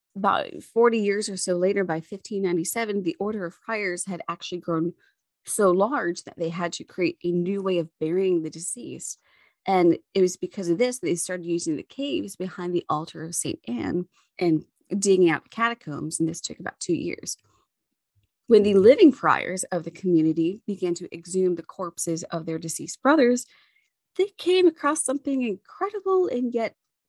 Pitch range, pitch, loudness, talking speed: 170-230 Hz, 185 Hz, -25 LUFS, 180 wpm